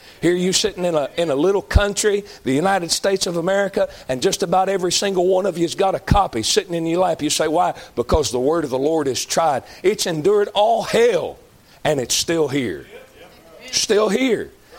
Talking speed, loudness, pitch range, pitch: 205 wpm, -19 LUFS, 170-205 Hz, 185 Hz